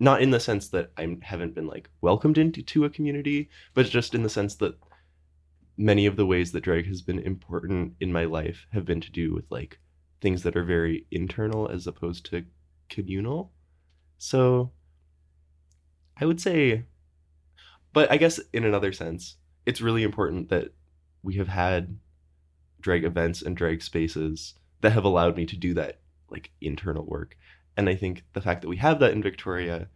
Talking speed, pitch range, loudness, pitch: 180 wpm, 75-100 Hz, -26 LUFS, 85 Hz